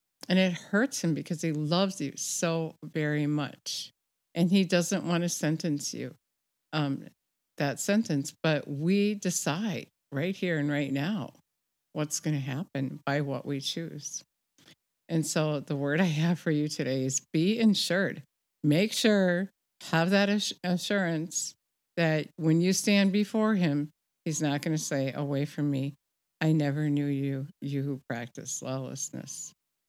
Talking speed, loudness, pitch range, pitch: 155 wpm, -29 LUFS, 145-180 Hz, 155 Hz